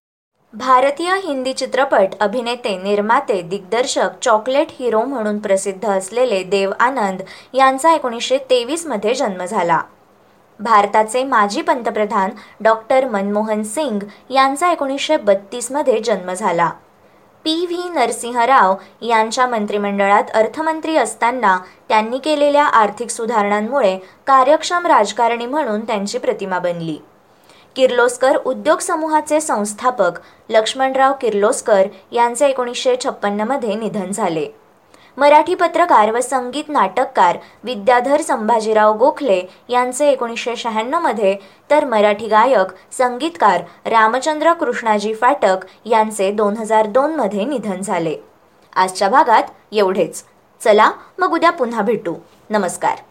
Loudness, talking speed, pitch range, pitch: -16 LUFS, 105 wpm, 210-275 Hz, 235 Hz